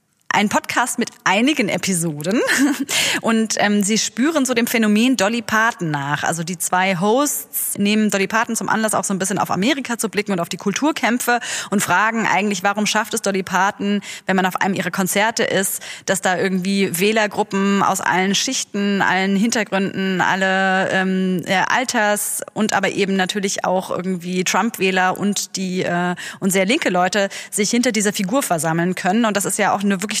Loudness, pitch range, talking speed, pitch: -18 LUFS, 190-225 Hz, 180 wpm, 200 Hz